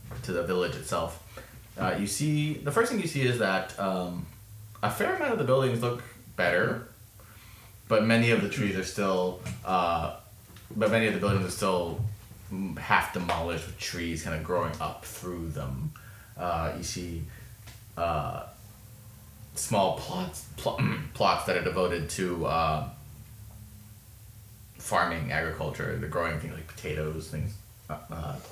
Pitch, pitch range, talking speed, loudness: 105 Hz, 90-115 Hz, 145 wpm, -29 LUFS